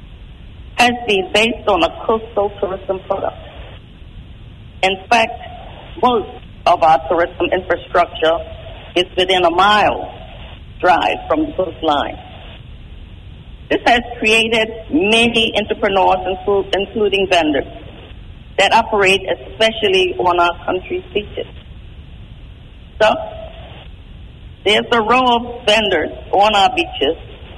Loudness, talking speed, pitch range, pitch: -15 LUFS, 100 wpm, 160-230 Hz, 195 Hz